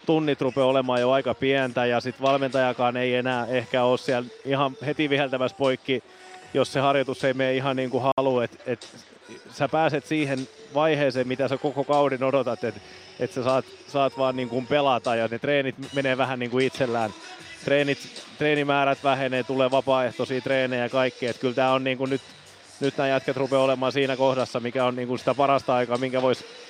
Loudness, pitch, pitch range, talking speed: -24 LUFS, 130 Hz, 125-140 Hz, 195 wpm